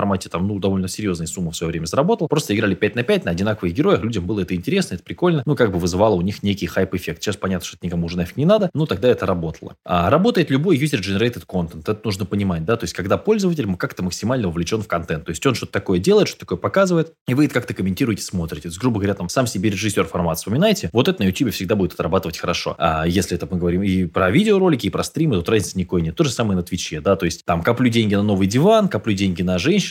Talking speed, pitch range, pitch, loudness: 255 wpm, 90-125 Hz, 100 Hz, -20 LUFS